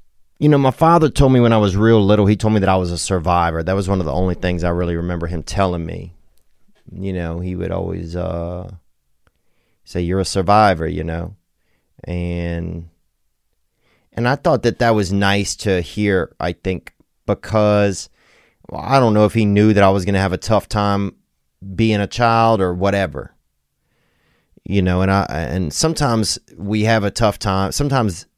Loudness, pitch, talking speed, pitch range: -17 LUFS, 95 Hz, 190 wpm, 85-105 Hz